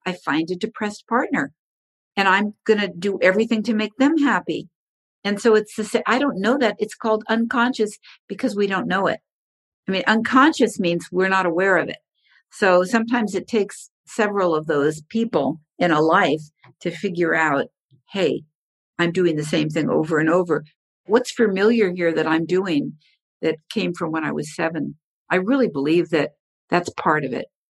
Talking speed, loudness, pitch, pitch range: 180 wpm, -21 LUFS, 190 Hz, 165-220 Hz